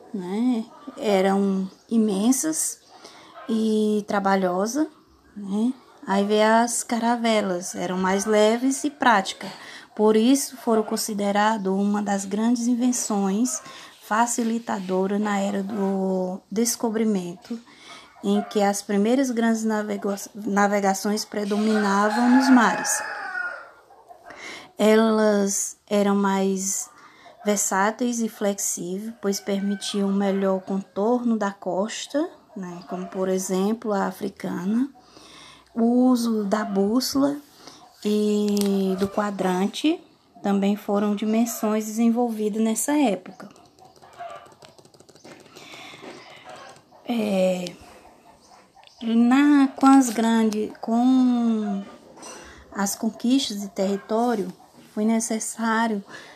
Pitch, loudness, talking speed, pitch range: 215 Hz, -23 LUFS, 85 wpm, 200-235 Hz